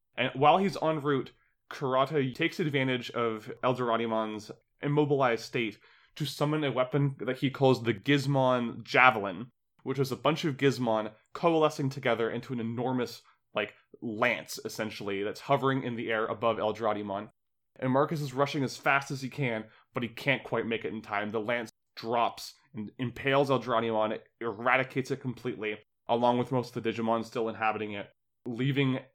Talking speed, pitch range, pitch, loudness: 165 wpm, 115-140 Hz, 125 Hz, -30 LUFS